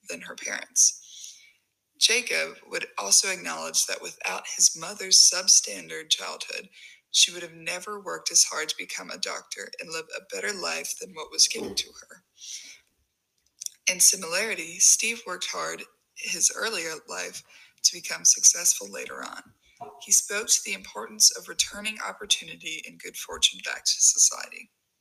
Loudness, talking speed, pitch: -22 LUFS, 150 wpm, 240 Hz